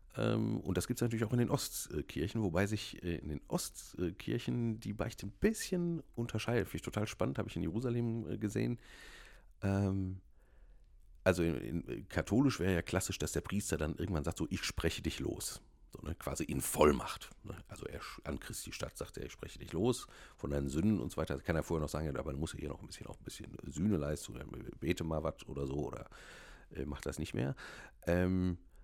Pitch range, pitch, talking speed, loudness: 80-110 Hz, 95 Hz, 205 wpm, -37 LUFS